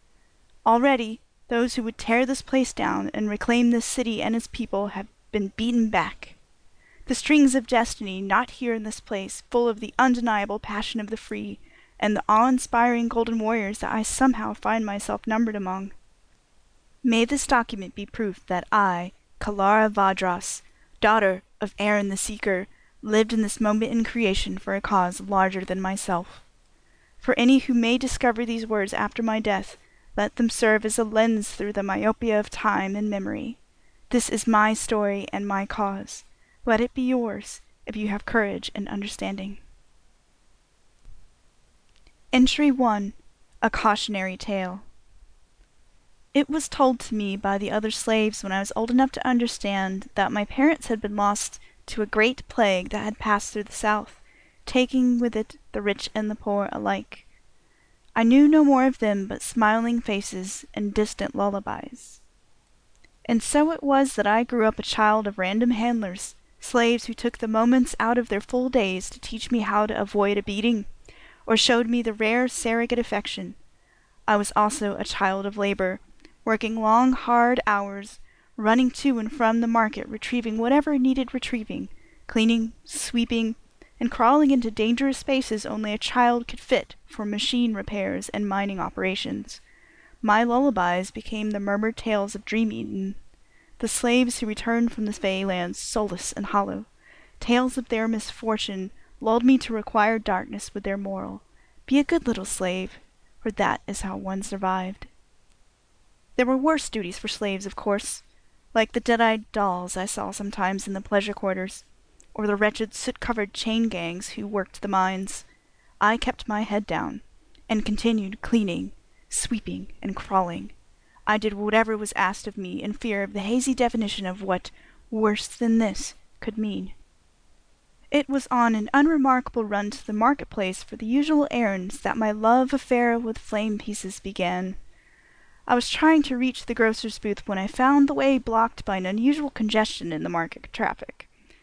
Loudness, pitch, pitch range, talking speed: -24 LUFS, 220 Hz, 200-240 Hz, 170 wpm